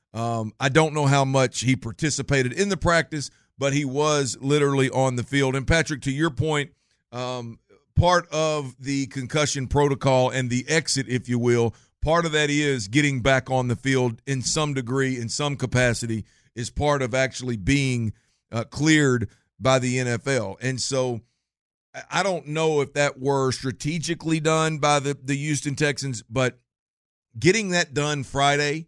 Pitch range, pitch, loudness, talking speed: 125-150 Hz, 135 Hz, -23 LUFS, 165 wpm